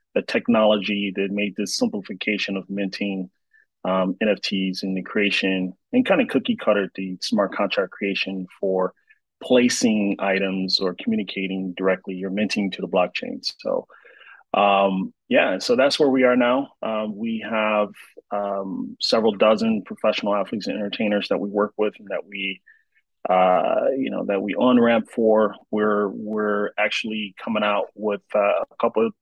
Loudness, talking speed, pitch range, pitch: -22 LUFS, 160 wpm, 95-110 Hz, 105 Hz